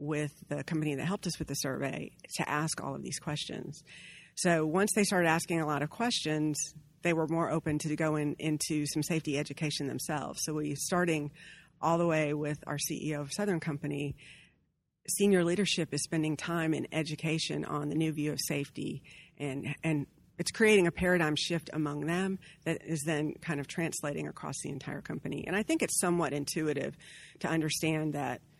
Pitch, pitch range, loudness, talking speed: 155 Hz, 150-170 Hz, -32 LUFS, 185 wpm